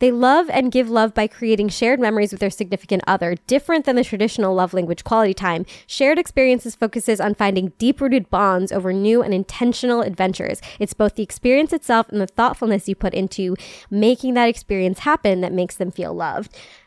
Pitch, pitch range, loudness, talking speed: 215 Hz, 195-245 Hz, -19 LUFS, 190 wpm